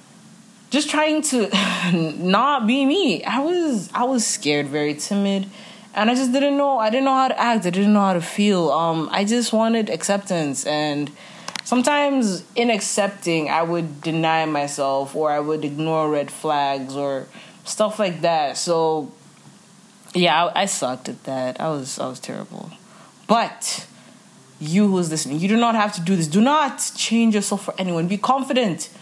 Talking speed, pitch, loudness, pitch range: 175 wpm, 200 Hz, -20 LUFS, 160-230 Hz